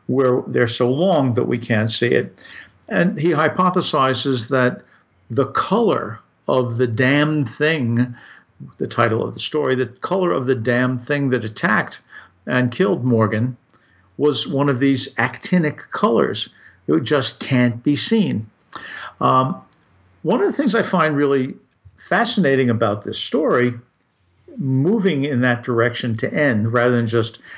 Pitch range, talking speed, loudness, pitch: 120-150 Hz, 145 wpm, -18 LUFS, 130 Hz